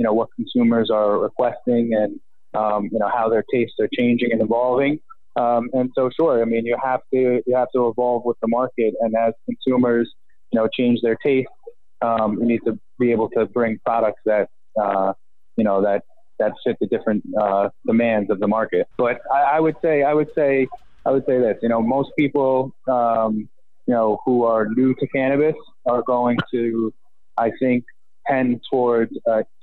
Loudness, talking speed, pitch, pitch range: -20 LUFS, 195 wpm, 120 Hz, 115-130 Hz